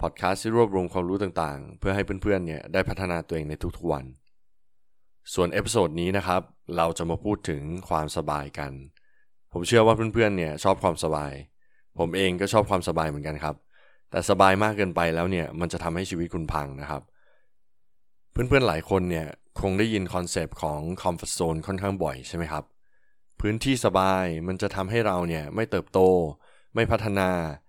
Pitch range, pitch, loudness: 80-95 Hz, 90 Hz, -26 LUFS